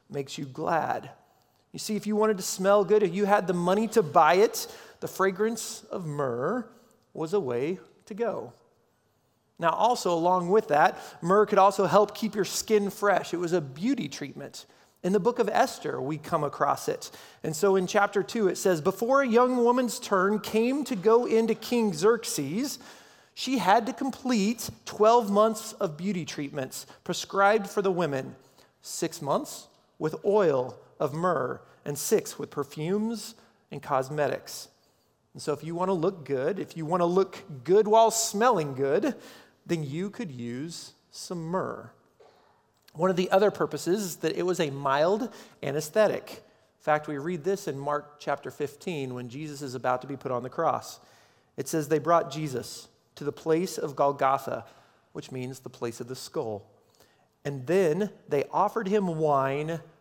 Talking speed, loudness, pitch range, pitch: 175 wpm, -27 LUFS, 150-220 Hz, 190 Hz